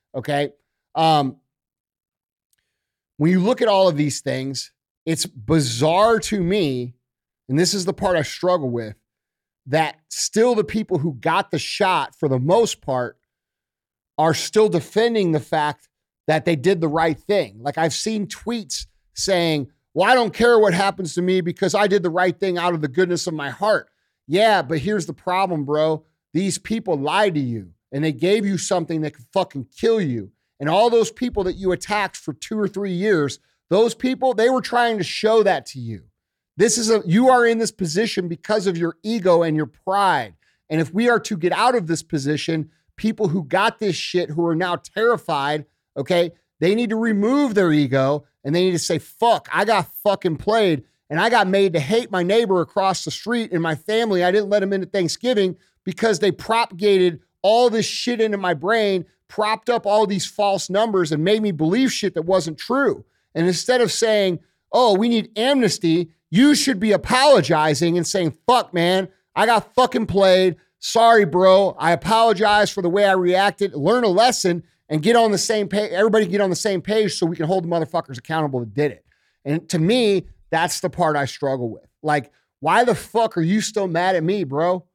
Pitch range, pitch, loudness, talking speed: 160-215 Hz, 185 Hz, -19 LUFS, 200 wpm